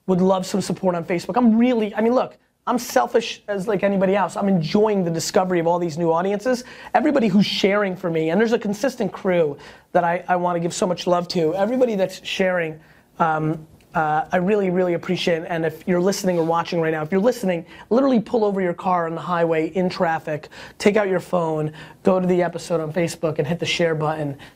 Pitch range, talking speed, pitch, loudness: 165-205 Hz, 225 wpm, 180 Hz, -21 LUFS